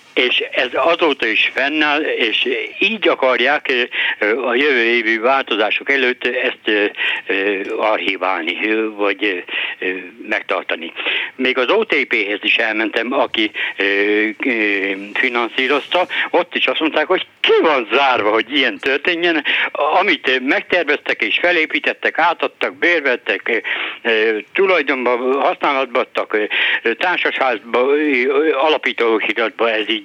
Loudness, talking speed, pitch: -16 LUFS, 95 wpm, 165 Hz